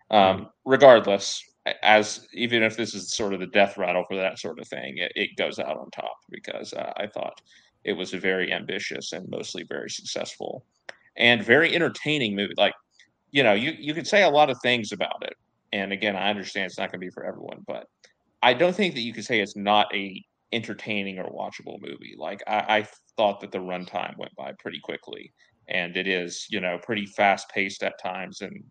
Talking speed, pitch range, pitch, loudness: 210 wpm, 95-115 Hz, 100 Hz, -24 LUFS